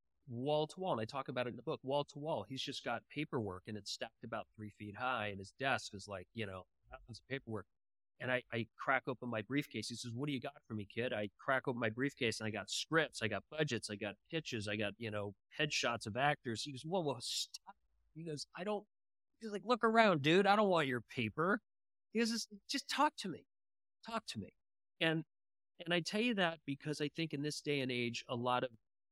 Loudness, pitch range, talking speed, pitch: -39 LUFS, 110-155 Hz, 245 wpm, 130 Hz